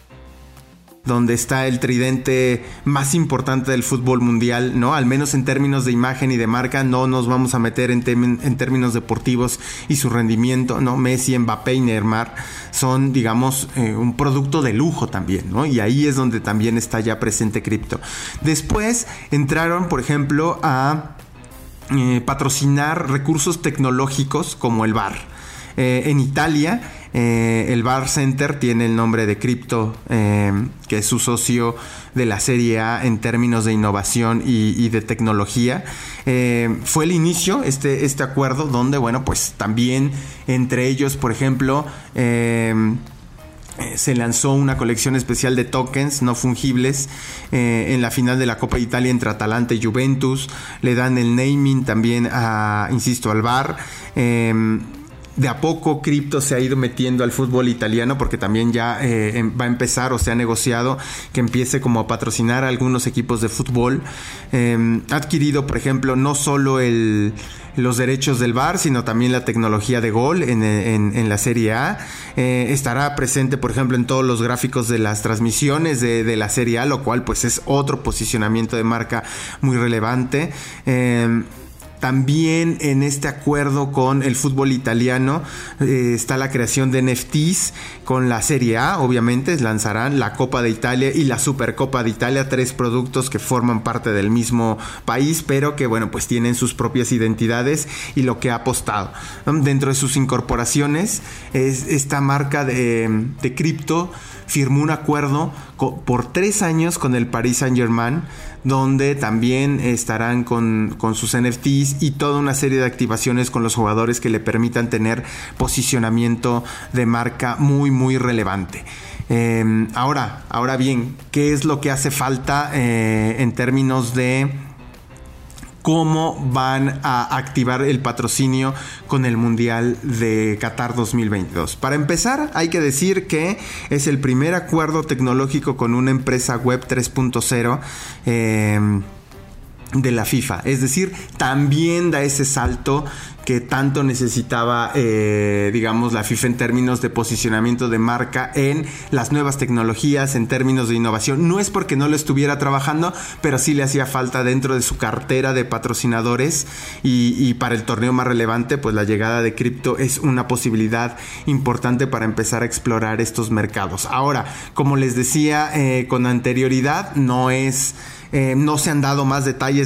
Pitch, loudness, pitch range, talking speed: 125 Hz, -18 LUFS, 115-140 Hz, 160 wpm